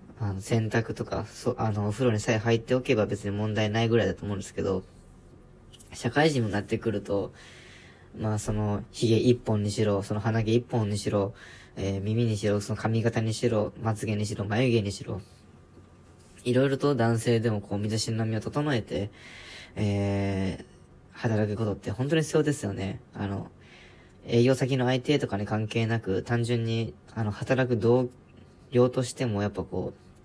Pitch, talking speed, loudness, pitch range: 110 Hz, 320 characters per minute, -28 LUFS, 100-120 Hz